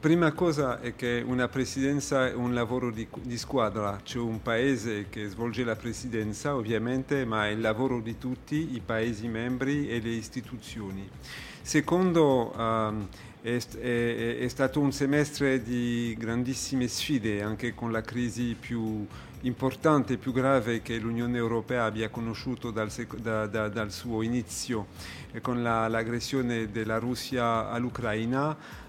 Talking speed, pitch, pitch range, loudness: 145 wpm, 120 Hz, 110-130 Hz, -29 LUFS